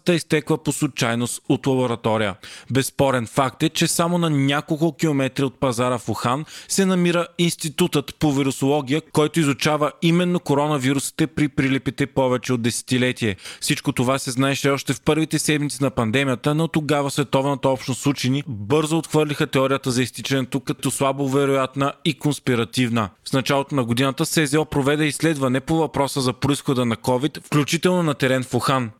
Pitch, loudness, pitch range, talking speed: 140 Hz, -21 LUFS, 130-155 Hz, 155 wpm